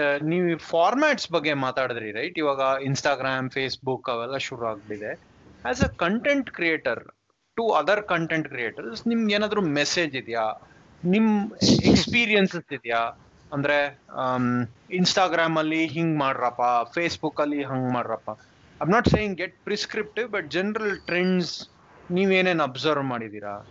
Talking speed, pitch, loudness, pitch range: 120 wpm, 155 Hz, -24 LUFS, 130-185 Hz